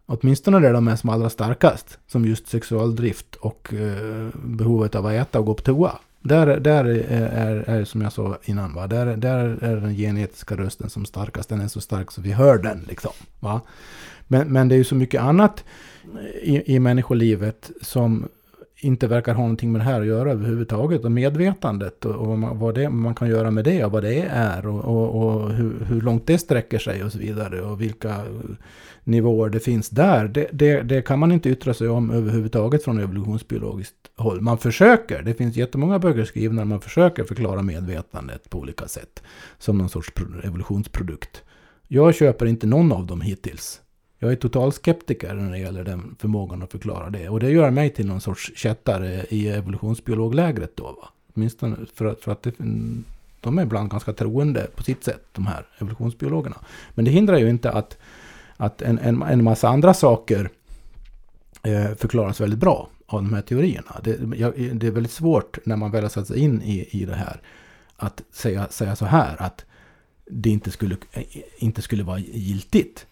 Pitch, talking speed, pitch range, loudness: 115 Hz, 190 wpm, 105-125 Hz, -21 LUFS